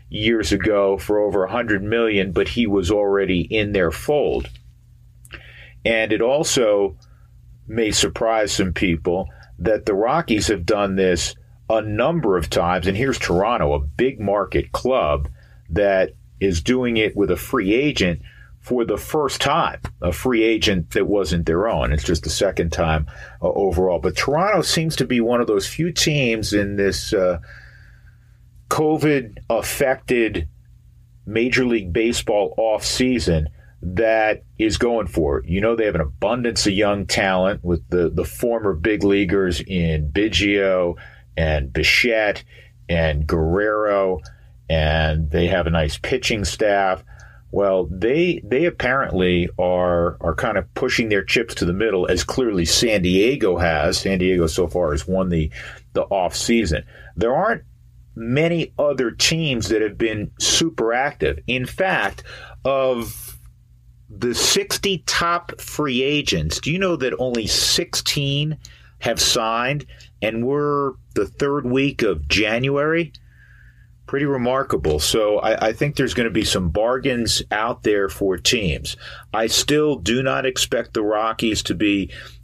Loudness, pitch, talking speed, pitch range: -20 LUFS, 105 Hz, 145 wpm, 90-120 Hz